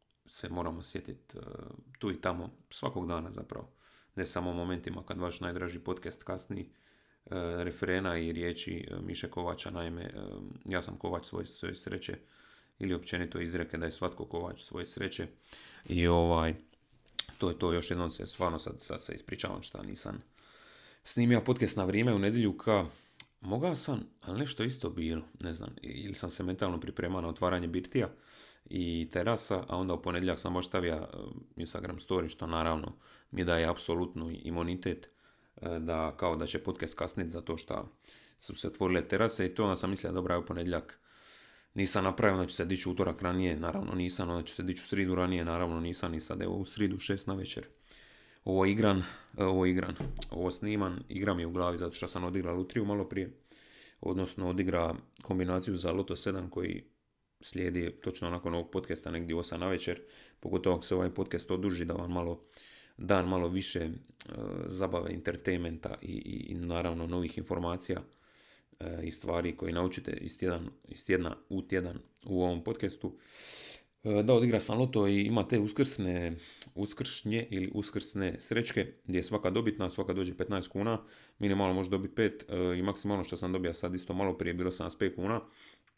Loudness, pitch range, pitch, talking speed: -34 LUFS, 85-95 Hz, 90 Hz, 170 wpm